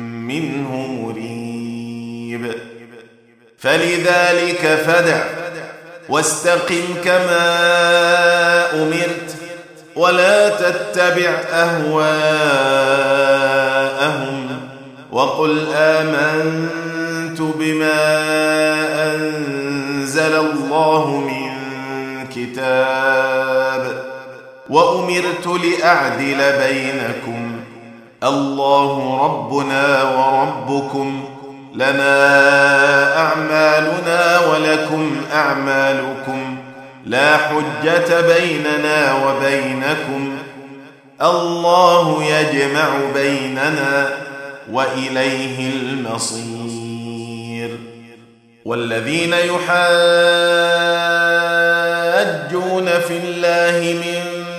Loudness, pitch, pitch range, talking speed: -15 LUFS, 140 Hz, 135-170 Hz, 45 wpm